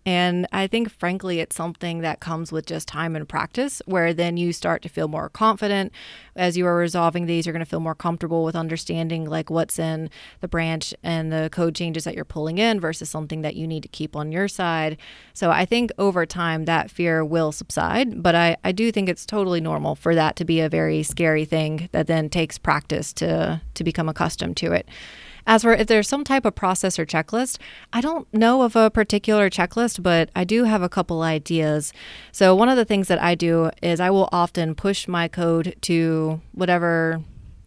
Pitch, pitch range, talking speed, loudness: 170 Hz, 160-190 Hz, 210 wpm, -22 LUFS